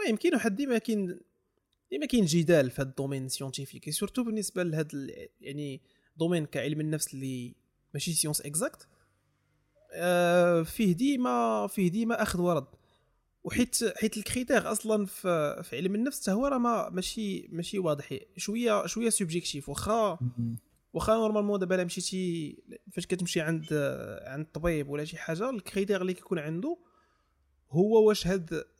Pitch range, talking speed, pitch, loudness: 150-215 Hz, 140 wpm, 180 Hz, -30 LUFS